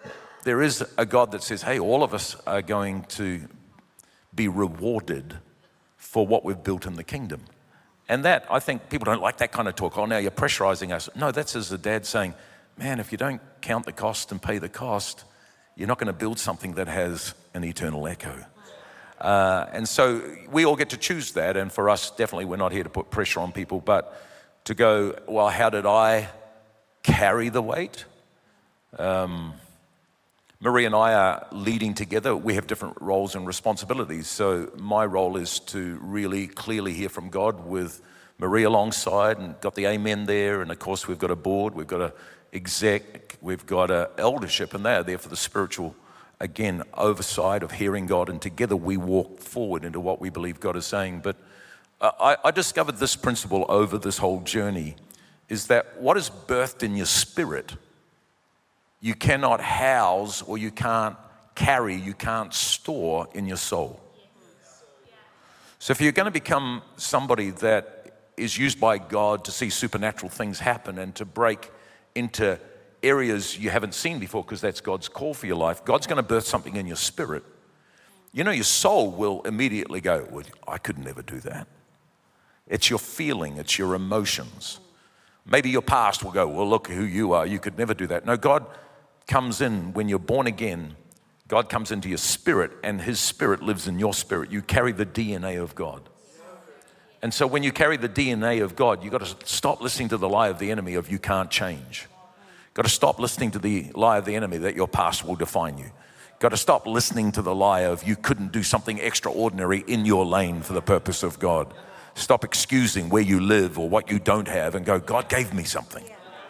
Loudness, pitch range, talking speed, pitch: -25 LUFS, 95-110 Hz, 195 wpm, 100 Hz